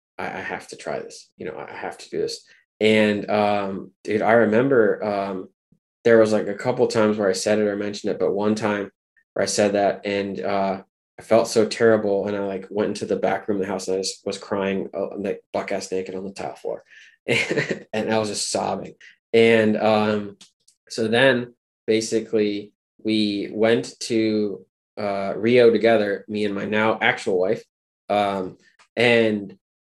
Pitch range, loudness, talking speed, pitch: 100-110 Hz, -22 LUFS, 185 wpm, 105 Hz